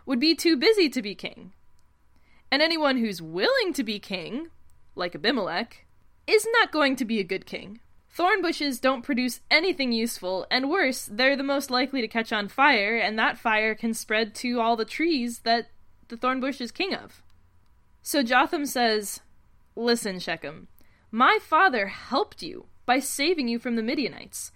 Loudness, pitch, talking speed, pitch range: -24 LUFS, 250 Hz, 170 wpm, 225-295 Hz